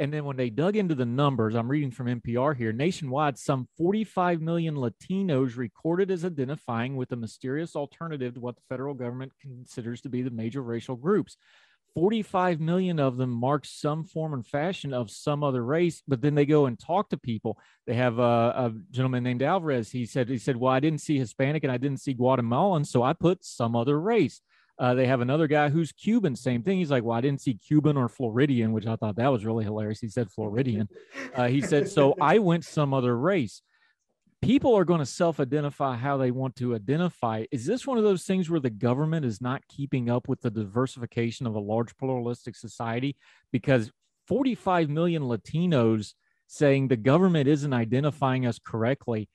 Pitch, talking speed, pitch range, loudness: 135 Hz, 200 wpm, 120-155 Hz, -27 LUFS